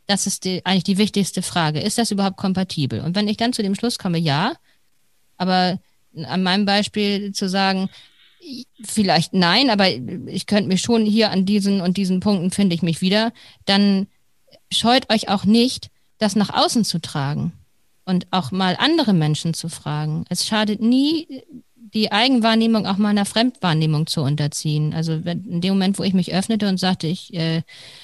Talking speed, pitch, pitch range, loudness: 180 wpm, 195 Hz, 175-215 Hz, -19 LUFS